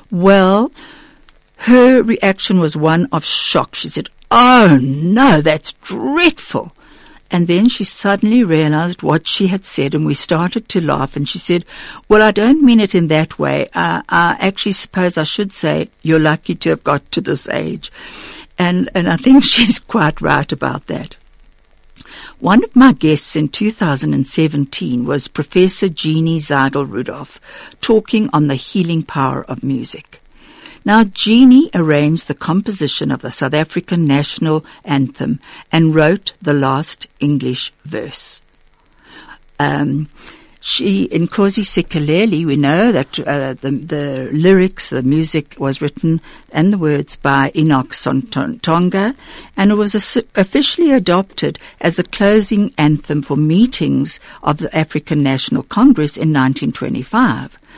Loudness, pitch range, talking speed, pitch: -14 LUFS, 145-210 Hz, 145 wpm, 165 Hz